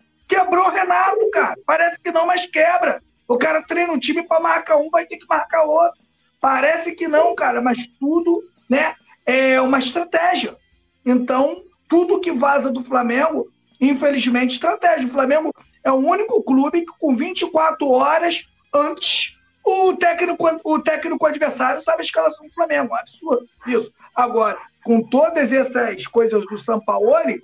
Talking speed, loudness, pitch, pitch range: 155 wpm, -18 LUFS, 310 Hz, 265-340 Hz